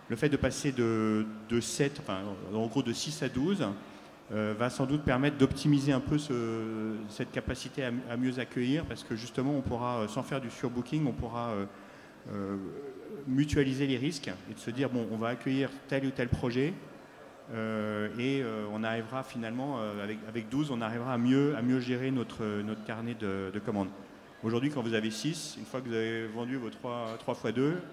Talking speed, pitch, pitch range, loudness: 205 wpm, 120 Hz, 110-135 Hz, -33 LUFS